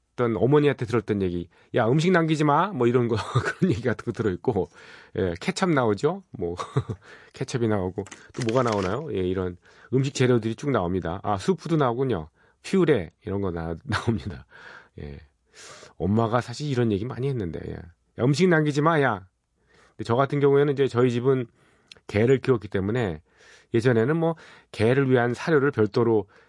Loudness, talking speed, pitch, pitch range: -24 LUFS, 335 characters per minute, 120 Hz, 100-140 Hz